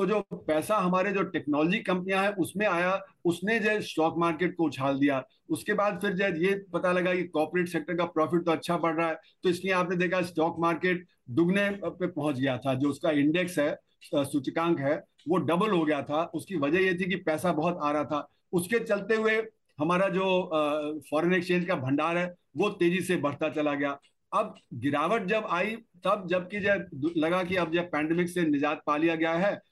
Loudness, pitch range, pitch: -28 LUFS, 155-190 Hz, 175 Hz